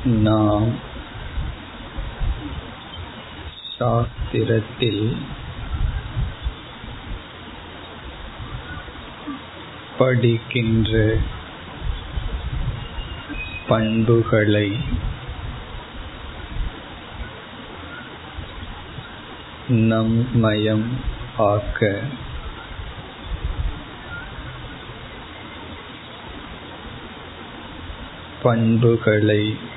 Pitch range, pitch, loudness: 105-115 Hz, 110 Hz, -22 LUFS